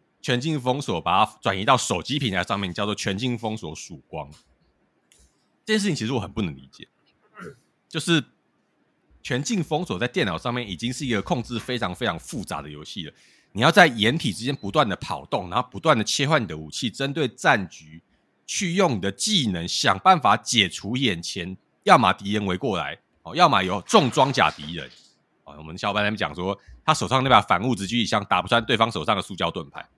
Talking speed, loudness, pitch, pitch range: 305 characters per minute, -23 LUFS, 110 Hz, 95-130 Hz